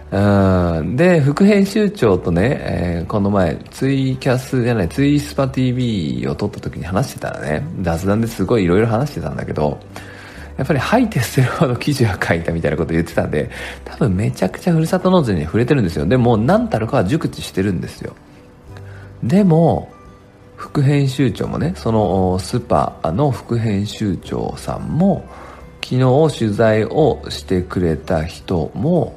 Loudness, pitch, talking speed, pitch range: -17 LUFS, 110 Hz, 325 characters per minute, 90-135 Hz